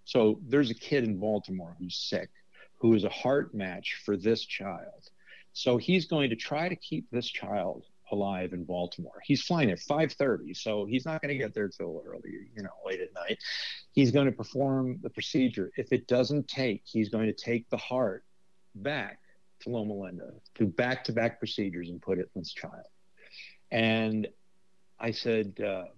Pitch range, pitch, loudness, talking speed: 105-140 Hz, 115 Hz, -31 LUFS, 185 wpm